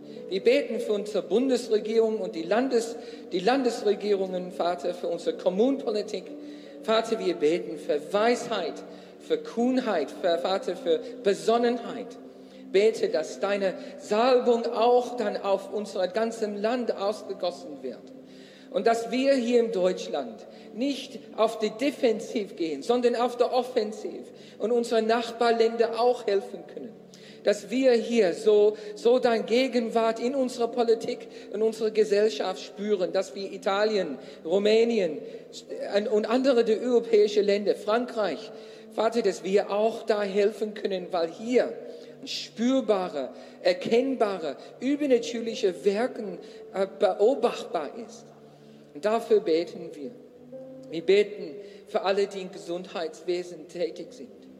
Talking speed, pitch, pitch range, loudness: 120 wpm, 225 Hz, 205-240 Hz, -26 LUFS